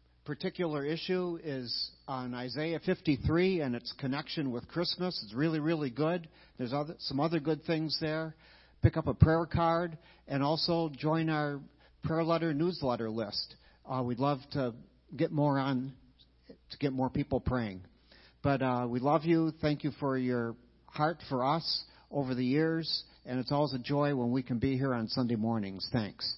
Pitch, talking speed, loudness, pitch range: 145 Hz, 175 wpm, -33 LUFS, 125-160 Hz